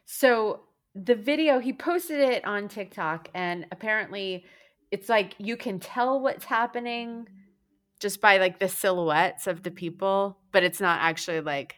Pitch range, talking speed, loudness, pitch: 180-235 Hz, 155 wpm, -26 LUFS, 200 Hz